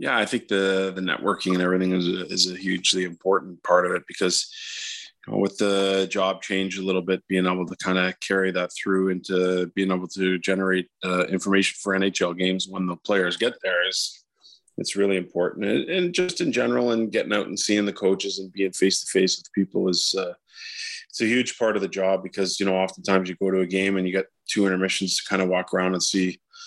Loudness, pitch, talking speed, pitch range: -24 LUFS, 95 Hz, 230 wpm, 95-100 Hz